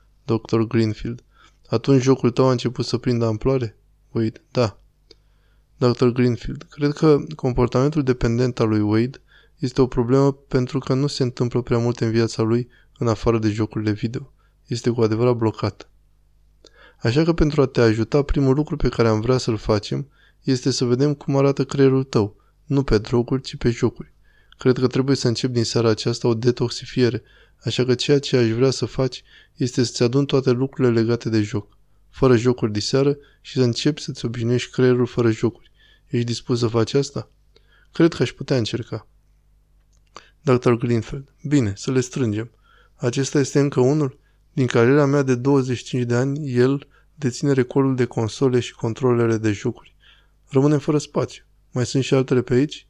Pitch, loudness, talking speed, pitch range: 125 Hz, -21 LUFS, 175 wpm, 115-135 Hz